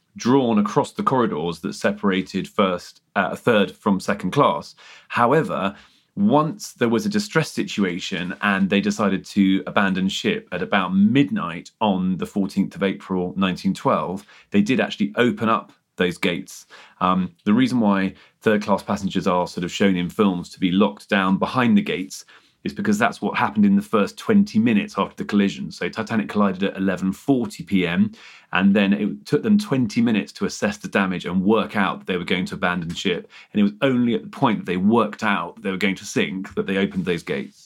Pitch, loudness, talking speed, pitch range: 100 Hz, -21 LUFS, 200 wpm, 95-150 Hz